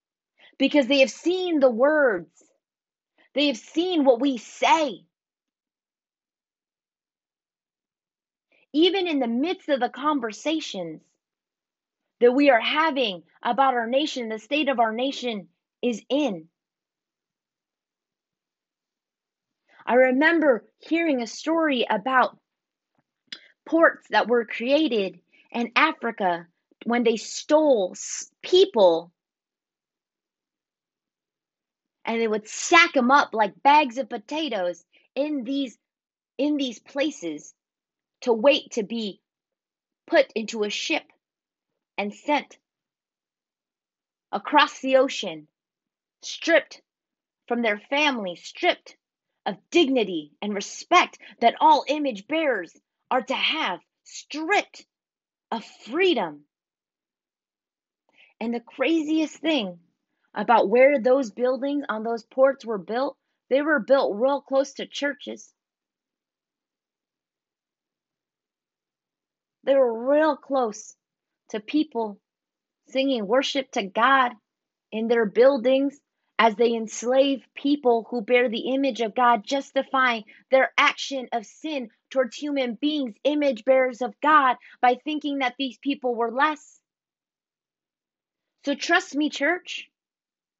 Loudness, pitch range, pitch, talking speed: -23 LUFS, 230-290 Hz, 265 Hz, 105 wpm